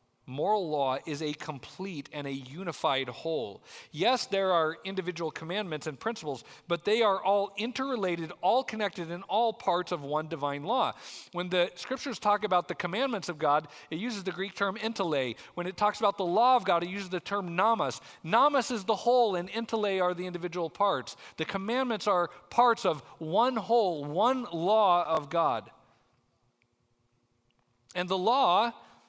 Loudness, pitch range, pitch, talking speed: -29 LUFS, 155-215 Hz, 180 Hz, 170 wpm